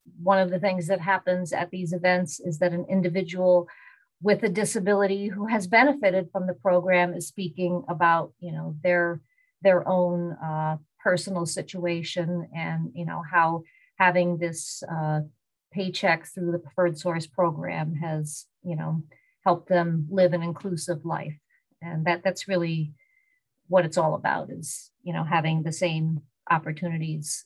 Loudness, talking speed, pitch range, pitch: -26 LUFS, 155 wpm, 165-185 Hz, 175 Hz